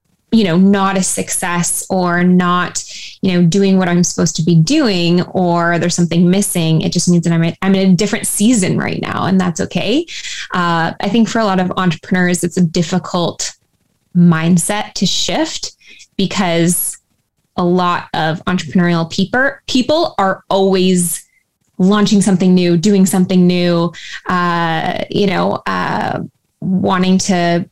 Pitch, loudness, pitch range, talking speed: 180 Hz, -14 LUFS, 175-195 Hz, 155 wpm